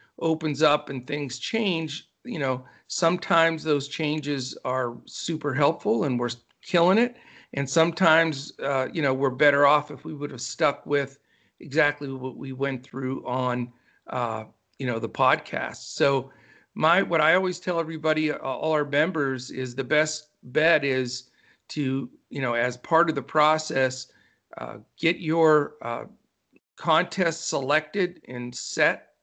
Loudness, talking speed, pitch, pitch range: -25 LUFS, 150 wpm, 145 Hz, 130-160 Hz